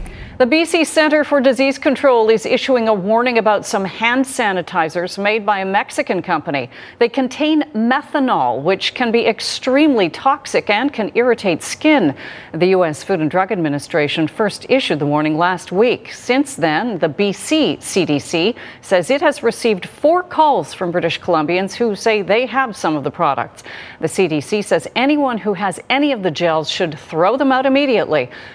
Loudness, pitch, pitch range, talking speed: -16 LUFS, 225 Hz, 180-270 Hz, 170 wpm